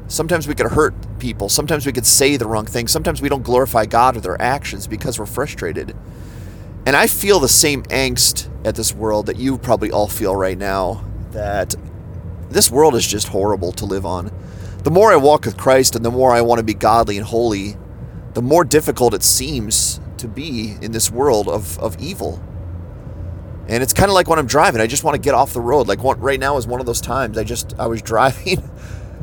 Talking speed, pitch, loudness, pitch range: 220 wpm, 115 Hz, -16 LUFS, 100-130 Hz